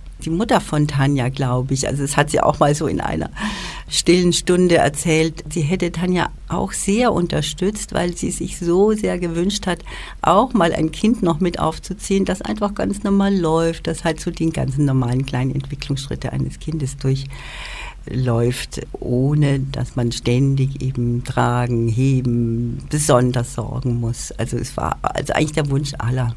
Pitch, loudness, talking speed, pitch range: 150 Hz, -19 LUFS, 165 wpm, 130-175 Hz